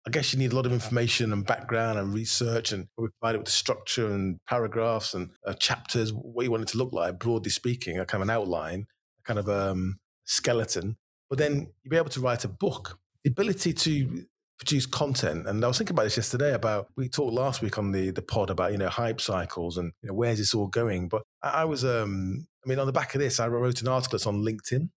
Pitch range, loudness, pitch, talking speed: 100-130 Hz, -28 LUFS, 115 Hz, 255 wpm